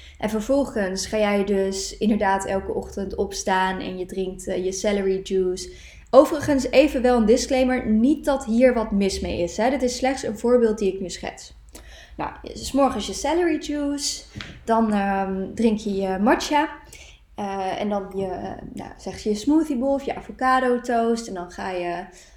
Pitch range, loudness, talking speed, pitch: 190-260 Hz, -22 LUFS, 180 wpm, 215 Hz